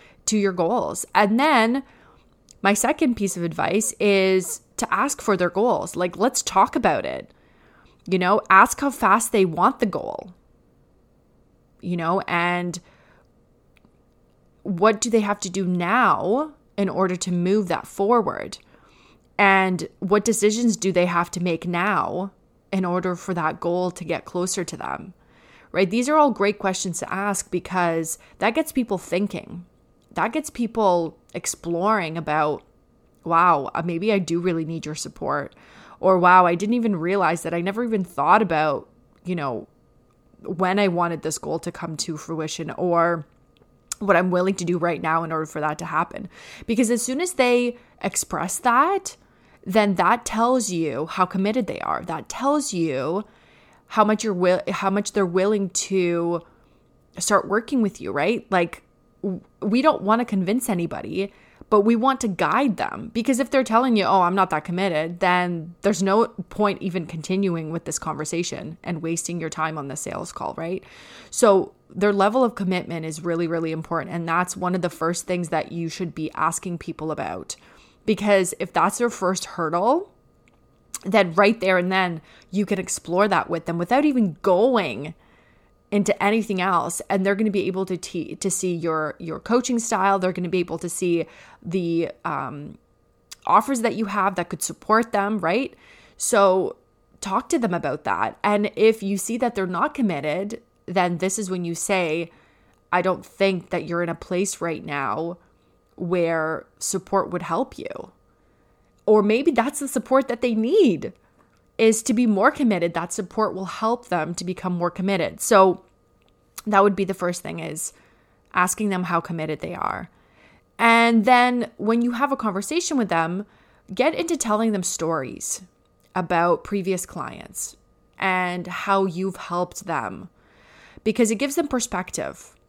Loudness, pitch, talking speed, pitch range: -22 LUFS, 190 Hz, 170 wpm, 175-215 Hz